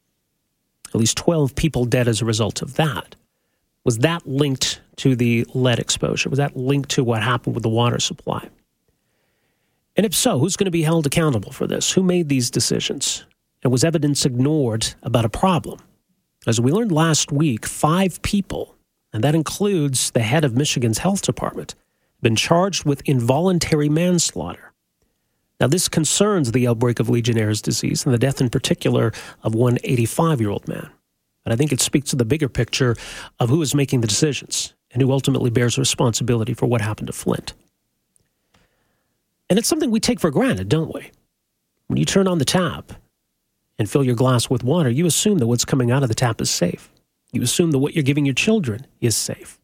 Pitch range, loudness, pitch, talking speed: 120-165 Hz, -19 LUFS, 135 Hz, 185 wpm